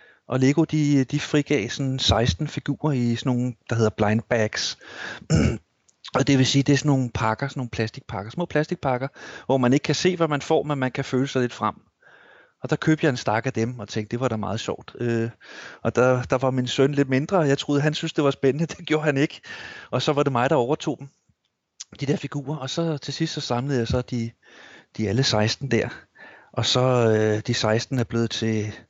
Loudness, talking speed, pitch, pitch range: -23 LUFS, 235 wpm, 130 Hz, 115-145 Hz